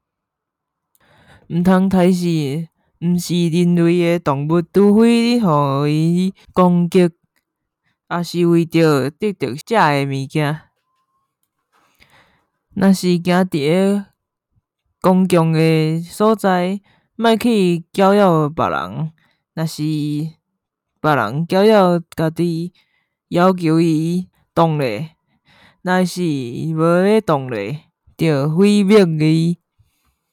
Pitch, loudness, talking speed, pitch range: 170 Hz, -16 LUFS, 135 characters per minute, 155-185 Hz